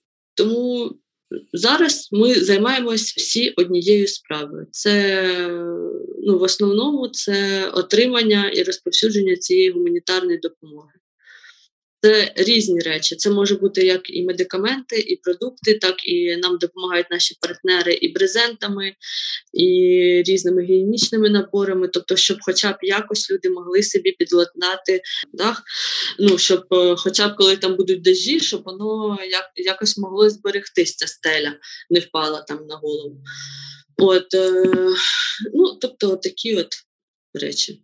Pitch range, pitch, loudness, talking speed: 180-255 Hz, 200 Hz, -18 LUFS, 120 wpm